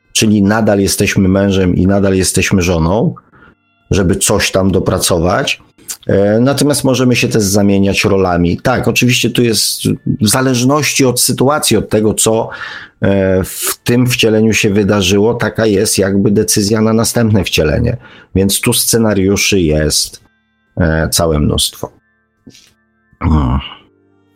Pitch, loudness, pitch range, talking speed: 105 Hz, -12 LUFS, 95-115 Hz, 120 wpm